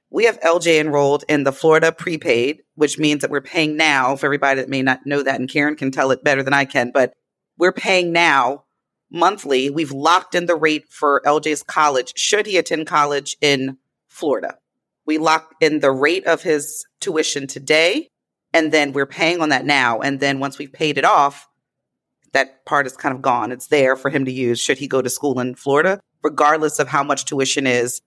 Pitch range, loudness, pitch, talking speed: 135-160 Hz, -18 LUFS, 145 Hz, 205 wpm